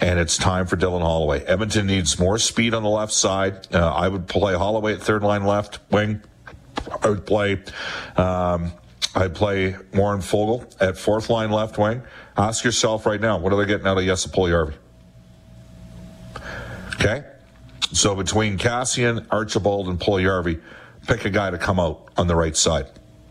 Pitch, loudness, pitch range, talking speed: 95 Hz, -21 LUFS, 90-105 Hz, 175 wpm